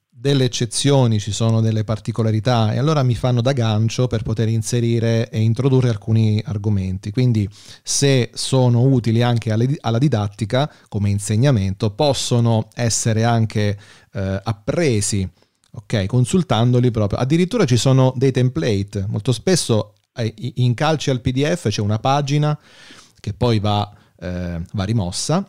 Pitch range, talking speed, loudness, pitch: 110-130 Hz, 130 wpm, -19 LUFS, 115 Hz